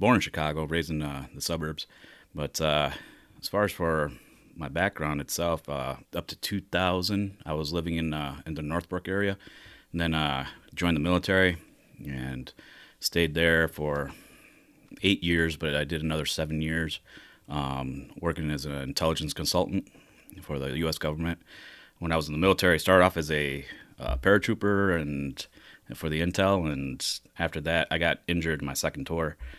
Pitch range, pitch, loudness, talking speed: 75-85 Hz, 80 Hz, -28 LUFS, 170 wpm